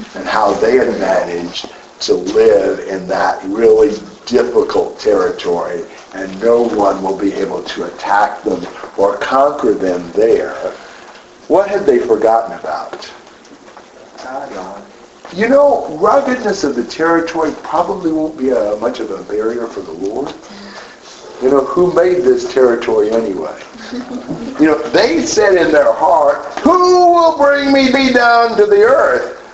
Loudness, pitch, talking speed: -13 LUFS, 335 Hz, 145 wpm